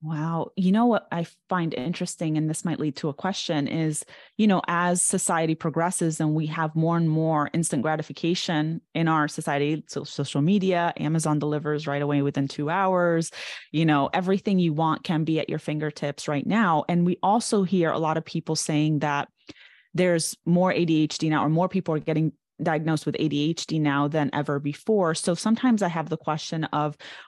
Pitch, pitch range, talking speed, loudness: 160 Hz, 150-175 Hz, 185 wpm, -25 LUFS